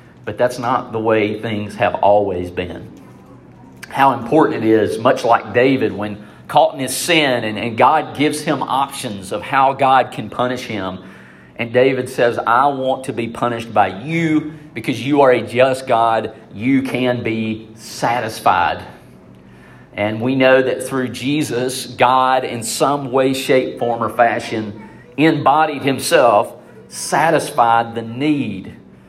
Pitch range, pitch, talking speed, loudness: 110-135 Hz, 120 Hz, 150 wpm, -16 LUFS